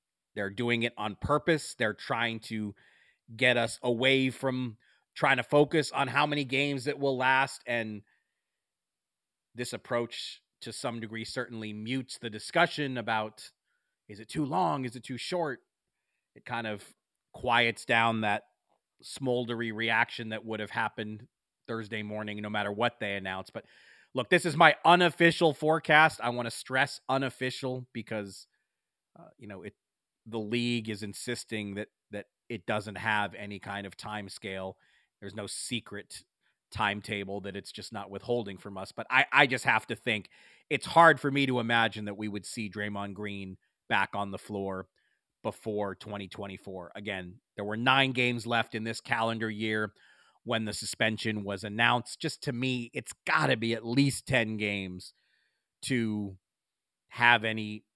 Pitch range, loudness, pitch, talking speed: 105-130 Hz, -29 LUFS, 115 Hz, 160 wpm